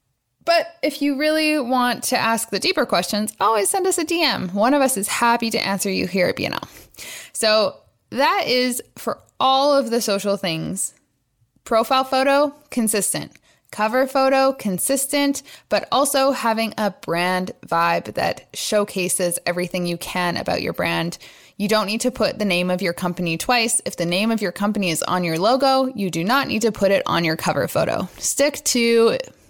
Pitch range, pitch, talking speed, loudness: 185-270 Hz, 225 Hz, 180 wpm, -20 LUFS